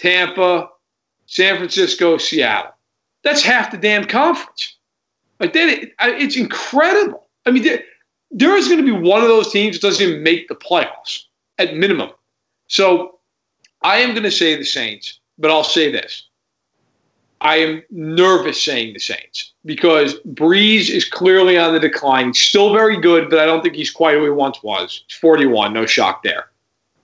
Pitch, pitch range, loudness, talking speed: 180 Hz, 160-225 Hz, -14 LUFS, 175 wpm